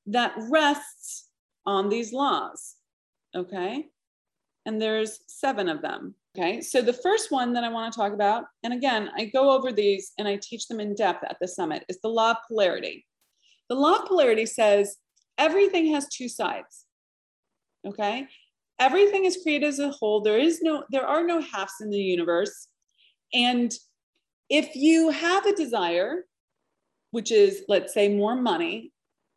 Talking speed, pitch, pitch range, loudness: 165 wpm, 245 Hz, 215-315 Hz, -25 LUFS